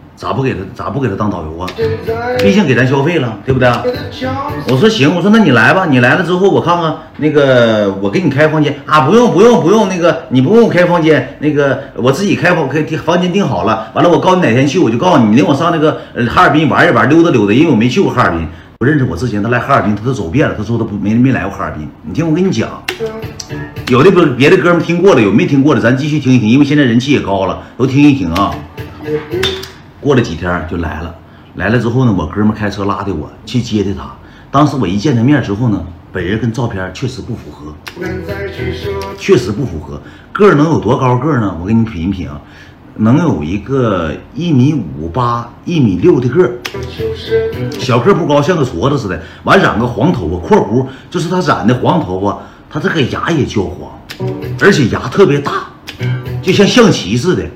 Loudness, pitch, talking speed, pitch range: -12 LUFS, 125 Hz, 315 characters per minute, 100-155 Hz